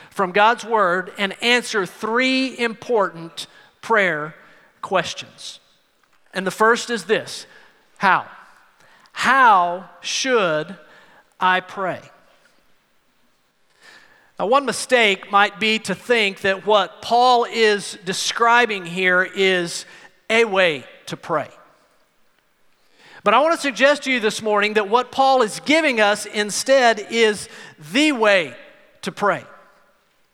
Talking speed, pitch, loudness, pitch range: 115 wpm, 215 Hz, -18 LUFS, 190-245 Hz